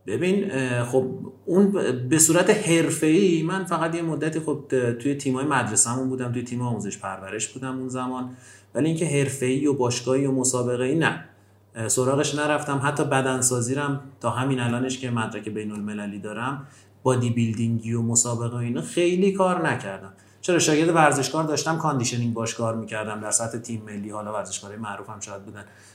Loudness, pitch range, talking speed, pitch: -23 LUFS, 110-145 Hz, 160 wpm, 125 Hz